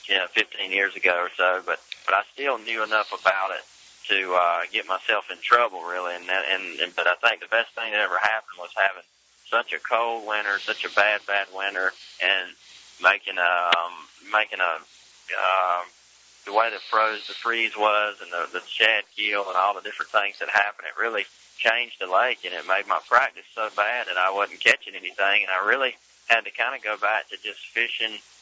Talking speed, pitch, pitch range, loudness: 210 wpm, 105 Hz, 95-110 Hz, -23 LUFS